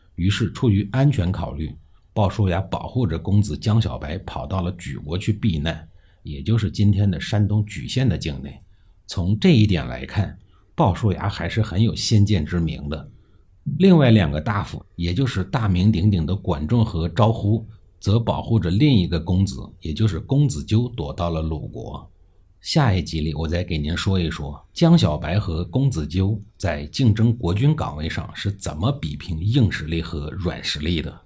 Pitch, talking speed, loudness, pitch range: 95 Hz, 260 characters per minute, -21 LUFS, 85-110 Hz